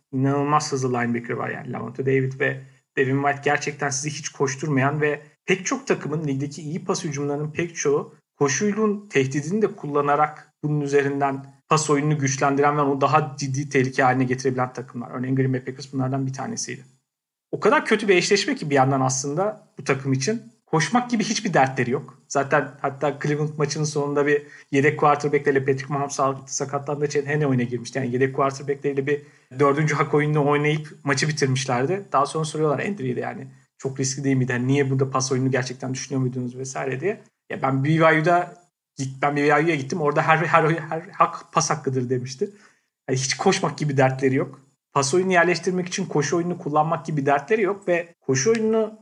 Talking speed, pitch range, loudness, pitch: 175 wpm, 135-160 Hz, -23 LUFS, 145 Hz